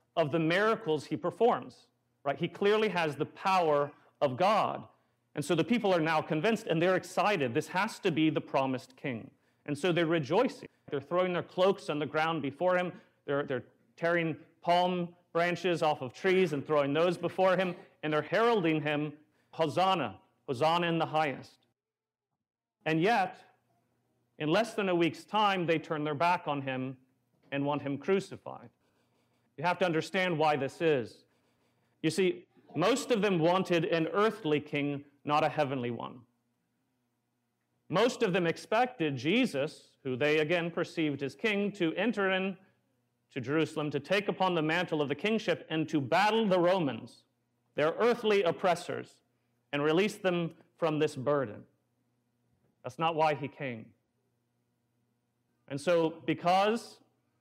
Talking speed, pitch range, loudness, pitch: 155 wpm, 135-180 Hz, -30 LUFS, 155 Hz